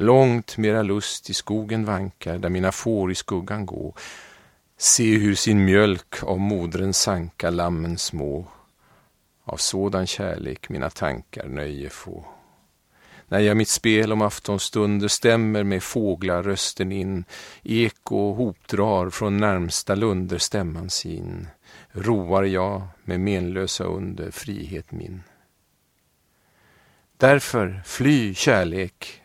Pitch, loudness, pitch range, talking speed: 95 Hz, -22 LUFS, 90-105 Hz, 115 wpm